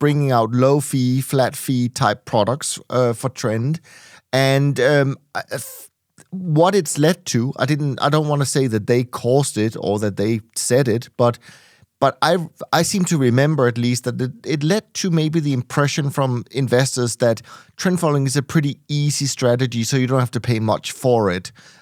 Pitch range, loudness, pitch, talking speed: 120-150 Hz, -19 LUFS, 135 Hz, 185 wpm